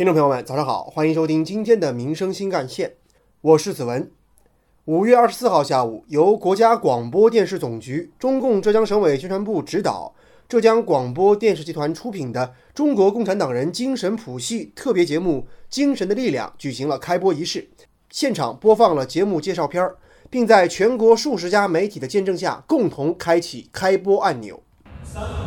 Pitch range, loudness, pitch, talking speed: 155-225 Hz, -20 LUFS, 185 Hz, 285 characters per minute